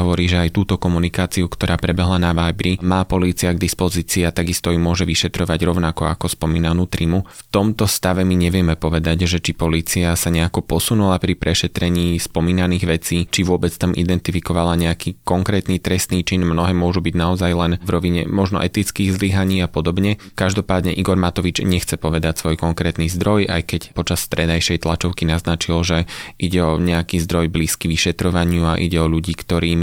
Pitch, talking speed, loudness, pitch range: 85 Hz, 170 wpm, -18 LUFS, 85-90 Hz